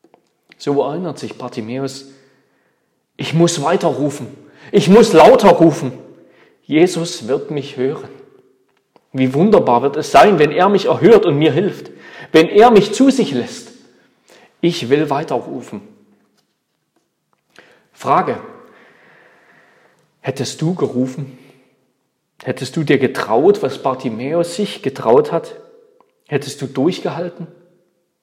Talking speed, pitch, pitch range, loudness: 110 wpm, 160 Hz, 135-180 Hz, -14 LUFS